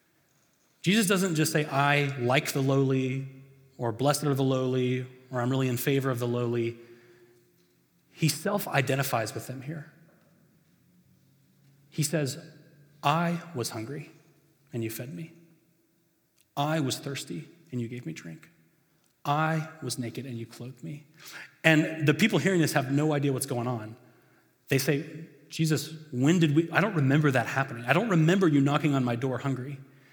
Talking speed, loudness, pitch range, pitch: 165 wpm, -27 LUFS, 130-160 Hz, 145 Hz